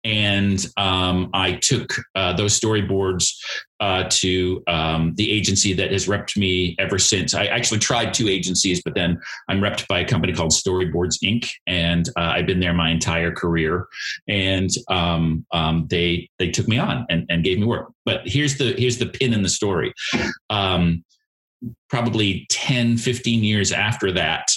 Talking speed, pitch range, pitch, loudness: 170 wpm, 85-110 Hz, 95 Hz, -20 LUFS